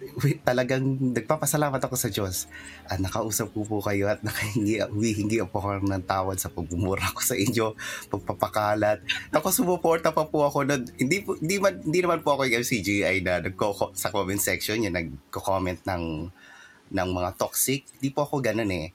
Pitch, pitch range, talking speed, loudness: 110 Hz, 95-135 Hz, 190 wpm, -26 LUFS